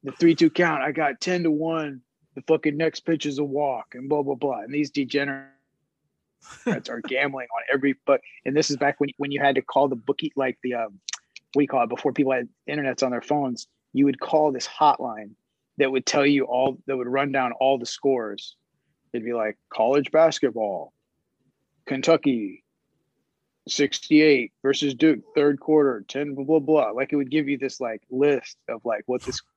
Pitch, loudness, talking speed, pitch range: 140 Hz, -24 LUFS, 195 wpm, 135-150 Hz